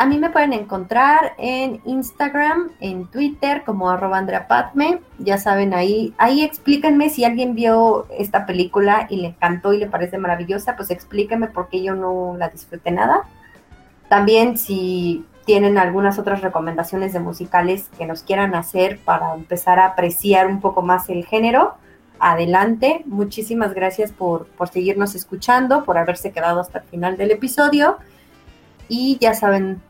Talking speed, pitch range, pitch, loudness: 155 wpm, 180-235 Hz, 200 Hz, -18 LUFS